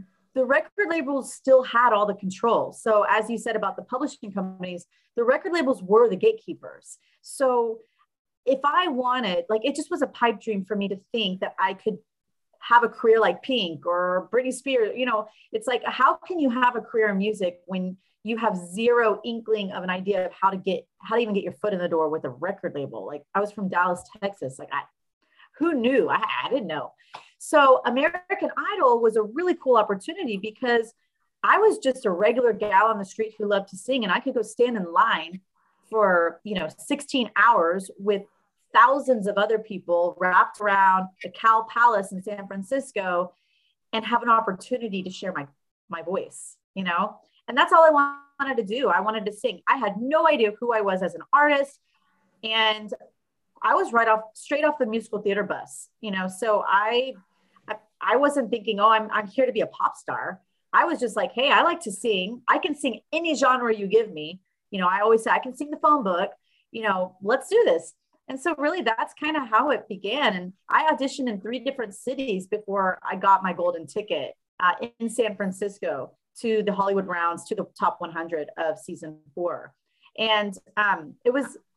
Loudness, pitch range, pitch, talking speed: -24 LUFS, 195-260 Hz, 220 Hz, 205 wpm